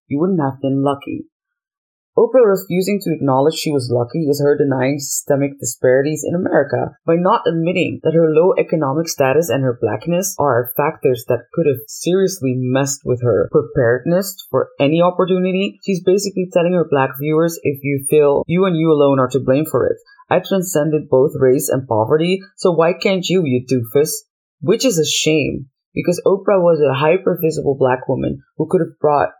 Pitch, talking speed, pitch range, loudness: 155 Hz, 180 wpm, 135-185 Hz, -16 LUFS